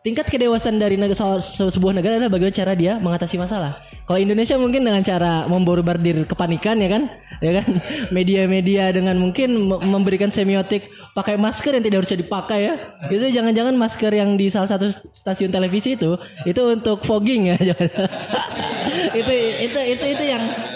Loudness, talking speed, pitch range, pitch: -19 LUFS, 165 wpm, 185-225 Hz, 200 Hz